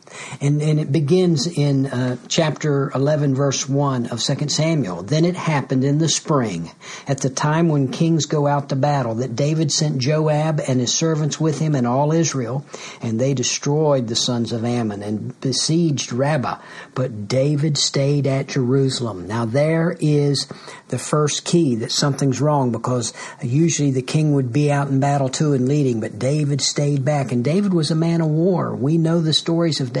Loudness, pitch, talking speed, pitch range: -19 LUFS, 145 Hz, 185 wpm, 130-155 Hz